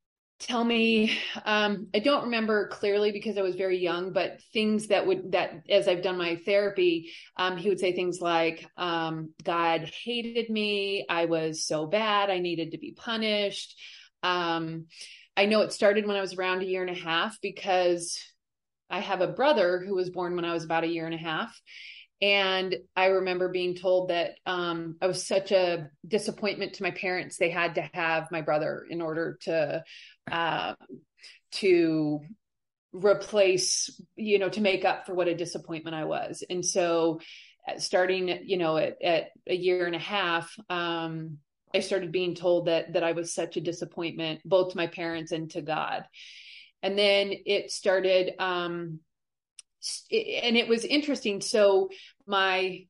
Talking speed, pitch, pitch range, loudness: 175 wpm, 185 Hz, 170-200 Hz, -28 LUFS